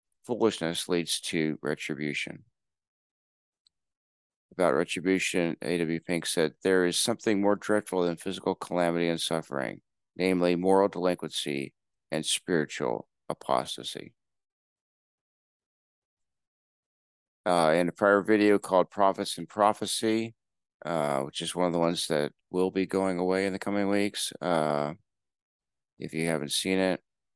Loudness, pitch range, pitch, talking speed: -28 LUFS, 80-100 Hz, 90 Hz, 125 wpm